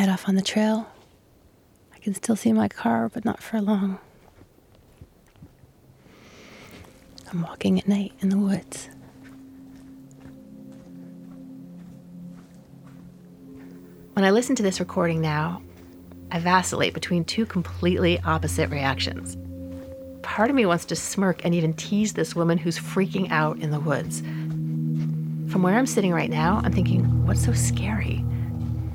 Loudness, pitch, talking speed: -24 LUFS, 135 Hz, 135 wpm